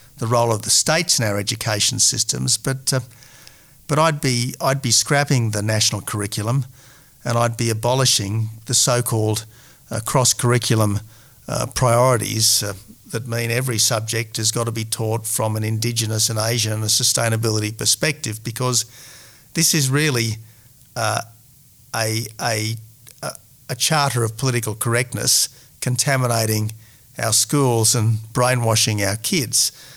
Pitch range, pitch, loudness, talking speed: 110-130 Hz, 120 Hz, -19 LUFS, 135 wpm